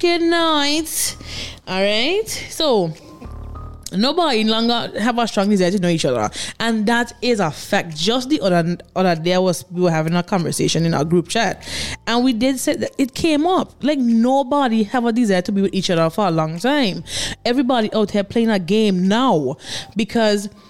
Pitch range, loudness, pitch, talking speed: 185-255 Hz, -18 LUFS, 220 Hz, 190 wpm